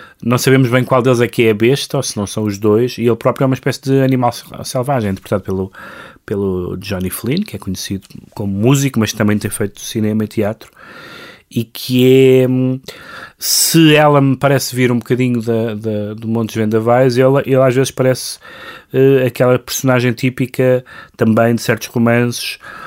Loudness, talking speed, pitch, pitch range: -14 LUFS, 185 wpm, 120 Hz, 110-130 Hz